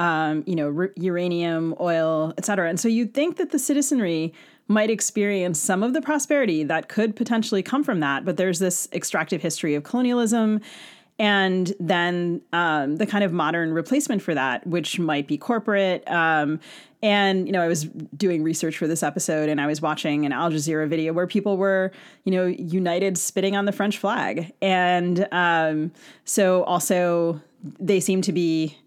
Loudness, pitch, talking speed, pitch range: -23 LUFS, 180 Hz, 180 wpm, 160-205 Hz